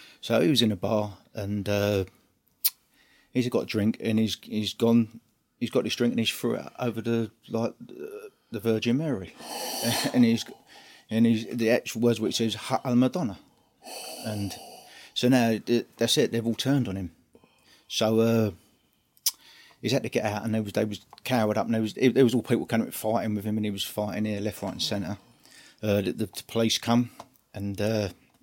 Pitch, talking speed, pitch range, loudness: 115 Hz, 200 wpm, 105-120 Hz, -27 LUFS